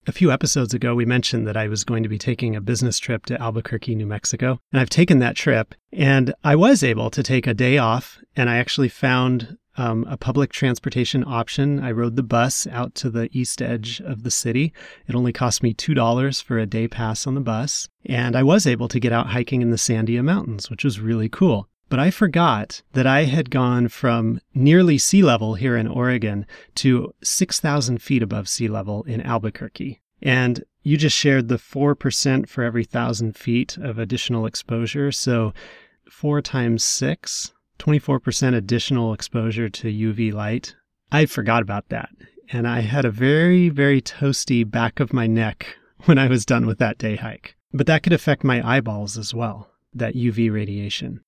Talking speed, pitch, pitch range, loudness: 190 wpm, 125 Hz, 115-135 Hz, -20 LUFS